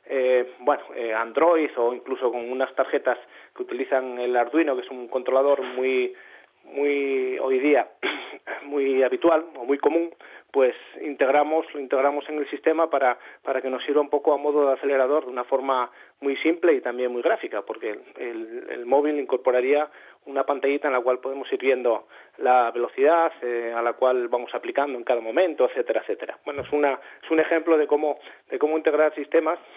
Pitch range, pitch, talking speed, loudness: 125-160 Hz, 140 Hz, 185 wpm, -24 LUFS